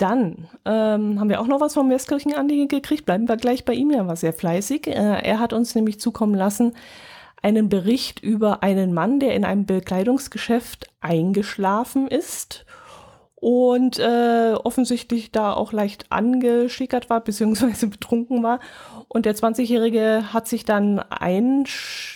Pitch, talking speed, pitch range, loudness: 230 Hz, 150 wpm, 210-250 Hz, -21 LUFS